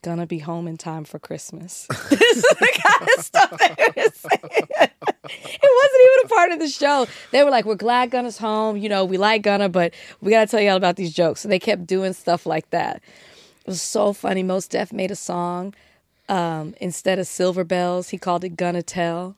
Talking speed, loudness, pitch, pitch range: 210 wpm, -19 LUFS, 190 Hz, 175-220 Hz